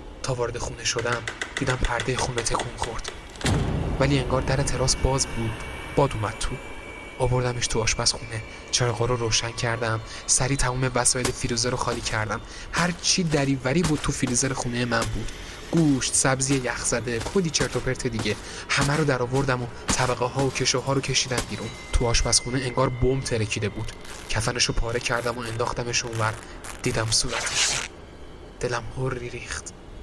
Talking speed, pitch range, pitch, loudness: 160 wpm, 115-130 Hz, 120 Hz, -25 LUFS